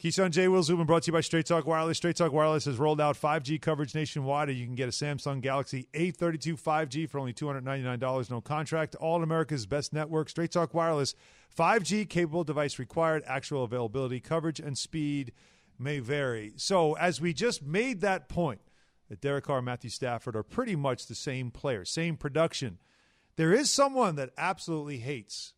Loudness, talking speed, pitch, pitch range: -30 LUFS, 185 wpm, 155 Hz, 135-165 Hz